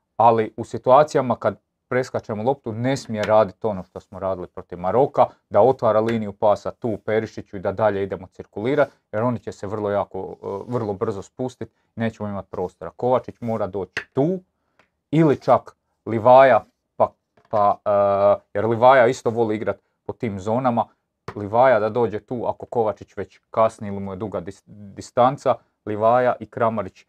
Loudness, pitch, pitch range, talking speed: -21 LUFS, 110 Hz, 100-120 Hz, 165 wpm